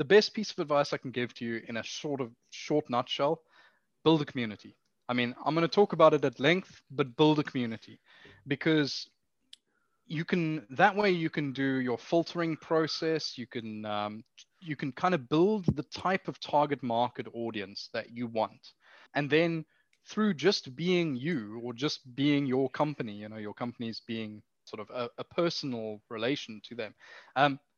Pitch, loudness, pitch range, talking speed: 140 Hz, -31 LUFS, 120-160 Hz, 185 wpm